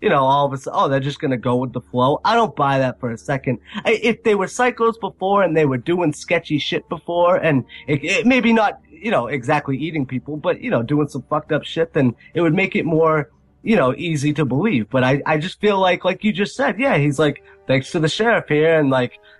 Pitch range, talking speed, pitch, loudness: 135-185 Hz, 255 wpm, 155 Hz, -19 LUFS